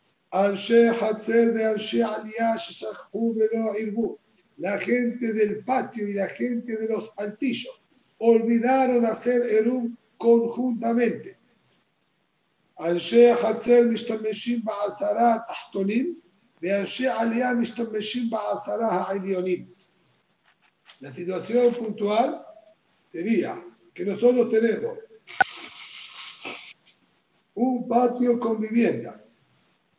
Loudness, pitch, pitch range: -24 LUFS, 230 Hz, 215-240 Hz